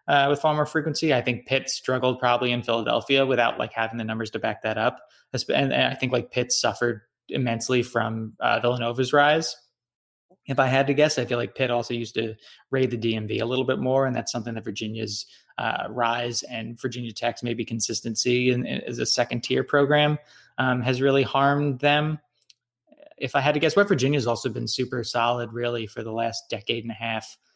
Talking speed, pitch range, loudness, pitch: 210 wpm, 115-135 Hz, -24 LUFS, 120 Hz